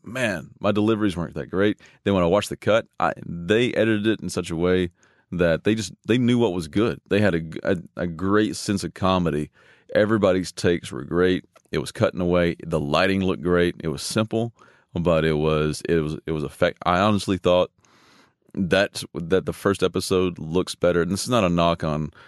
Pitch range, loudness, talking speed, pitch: 85-100 Hz, -23 LUFS, 210 wpm, 90 Hz